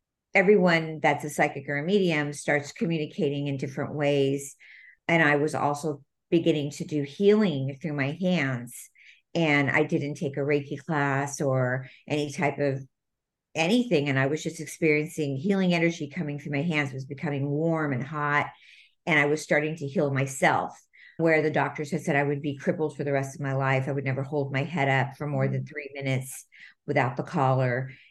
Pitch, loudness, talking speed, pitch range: 145 Hz, -26 LUFS, 190 wpm, 140-155 Hz